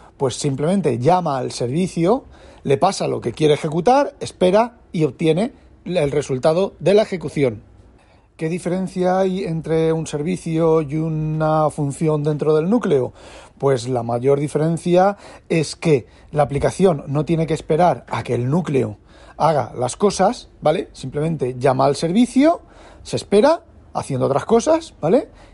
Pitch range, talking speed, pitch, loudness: 140-185 Hz, 145 wpm, 160 Hz, -19 LUFS